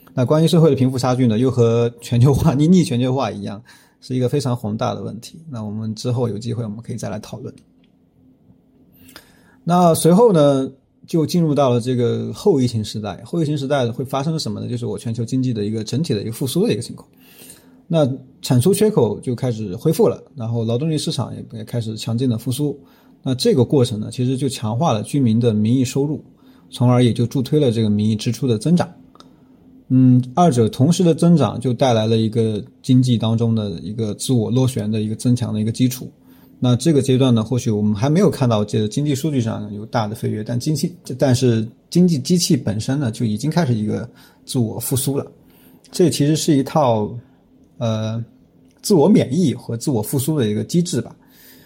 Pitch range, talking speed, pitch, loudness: 110-145 Hz, 310 characters per minute, 125 Hz, -18 LUFS